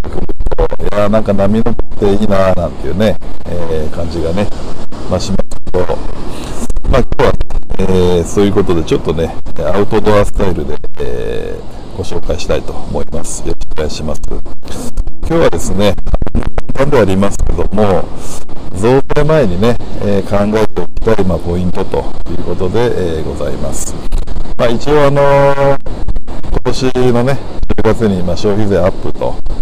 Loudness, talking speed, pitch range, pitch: -15 LUFS, 305 characters per minute, 90-120 Hz, 100 Hz